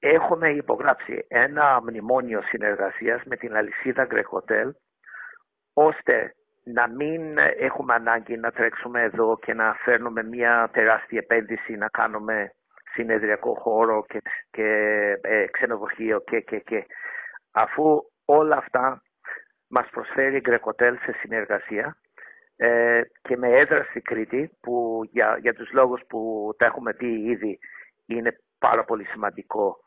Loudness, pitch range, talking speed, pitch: -23 LUFS, 115-155 Hz, 125 wpm, 120 Hz